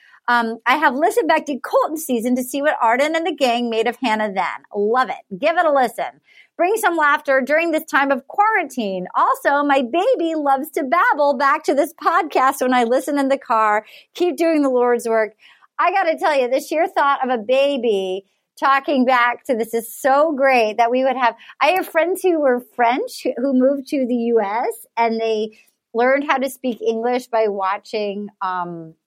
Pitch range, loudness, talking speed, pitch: 235-315 Hz, -18 LUFS, 200 wpm, 265 Hz